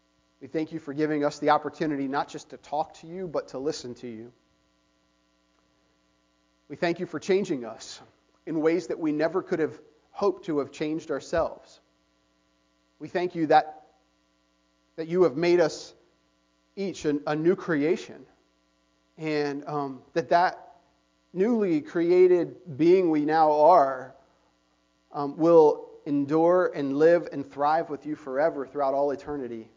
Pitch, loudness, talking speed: 145 Hz, -26 LUFS, 150 wpm